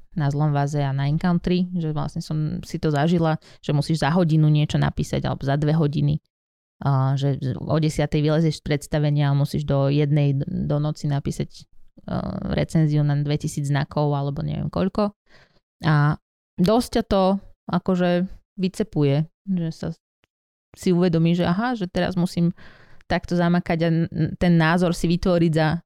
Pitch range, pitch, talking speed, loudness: 145-175 Hz, 160 Hz, 150 wpm, -22 LUFS